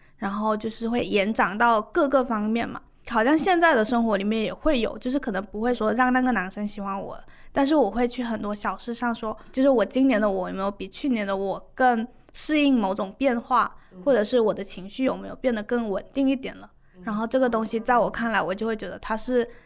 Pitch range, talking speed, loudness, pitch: 205-255 Hz, 330 characters per minute, -24 LUFS, 230 Hz